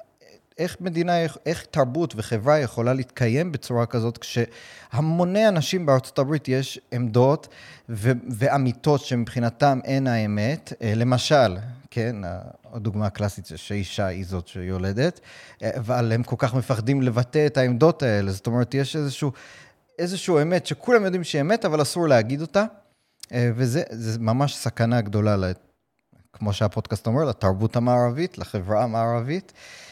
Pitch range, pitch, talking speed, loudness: 115-145 Hz, 125 Hz, 125 wpm, -23 LUFS